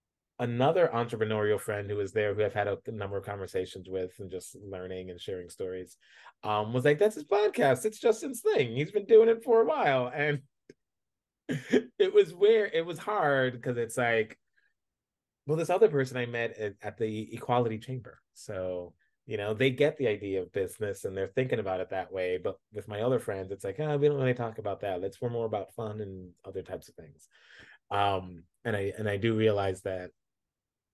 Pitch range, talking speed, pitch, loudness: 100-140 Hz, 210 wpm, 110 Hz, -30 LUFS